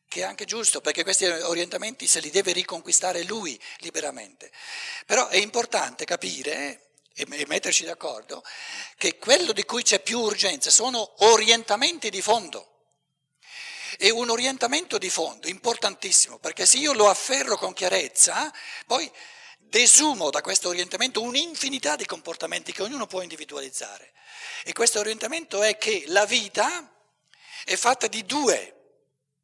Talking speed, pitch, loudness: 135 wpm, 235 Hz, -22 LUFS